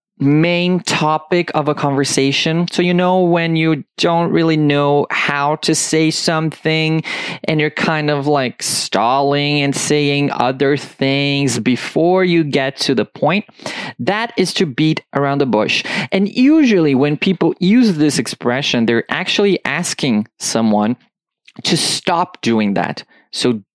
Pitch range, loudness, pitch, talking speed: 140-180 Hz, -15 LUFS, 155 Hz, 140 wpm